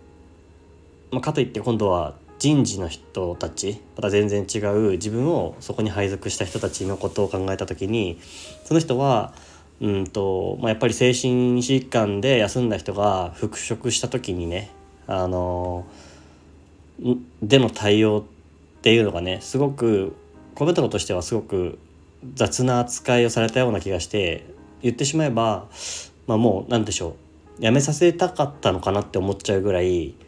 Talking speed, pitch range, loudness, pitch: 305 characters per minute, 90-120 Hz, -22 LUFS, 105 Hz